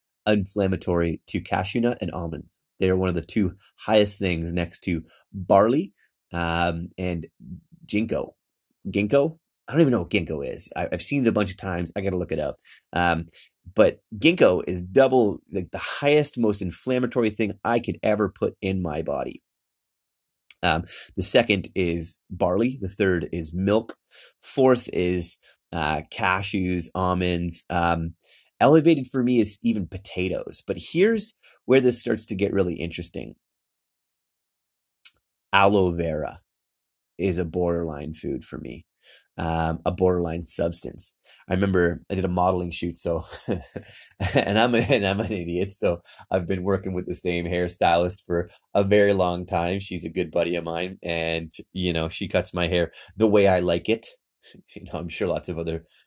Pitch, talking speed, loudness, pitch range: 90 Hz, 165 wpm, -23 LUFS, 85-105 Hz